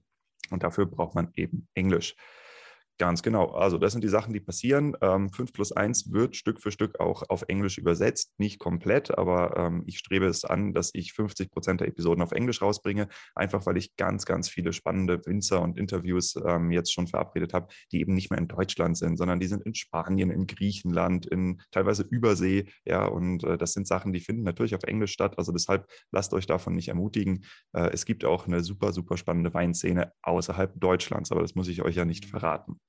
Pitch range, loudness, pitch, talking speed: 85-100 Hz, -28 LUFS, 95 Hz, 200 wpm